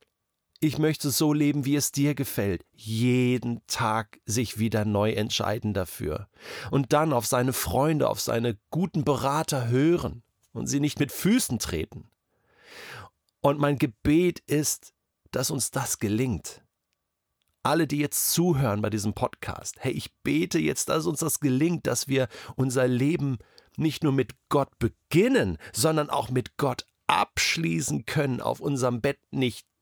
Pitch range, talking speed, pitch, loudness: 115-150 Hz, 145 wpm, 130 Hz, -26 LUFS